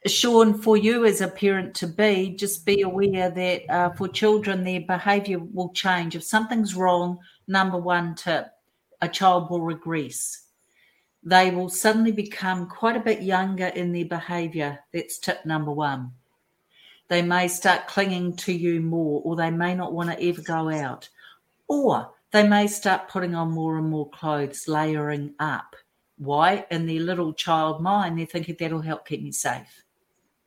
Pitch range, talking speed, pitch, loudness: 165-190 Hz, 165 wpm, 180 Hz, -24 LUFS